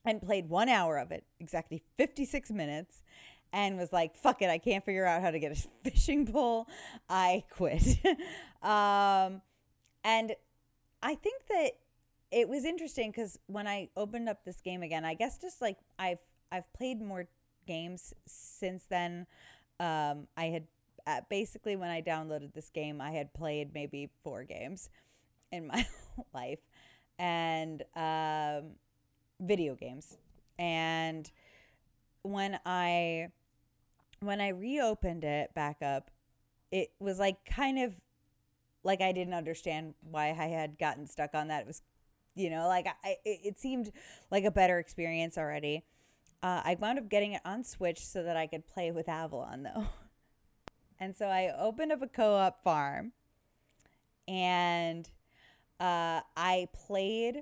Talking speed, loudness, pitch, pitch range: 150 wpm, -34 LUFS, 180 Hz, 160-210 Hz